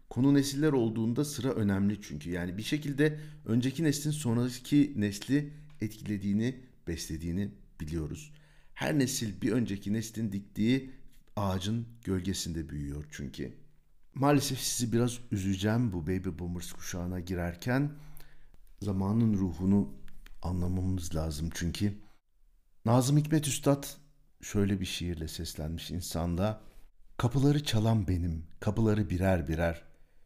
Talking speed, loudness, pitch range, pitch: 105 wpm, -31 LUFS, 90-130 Hz, 105 Hz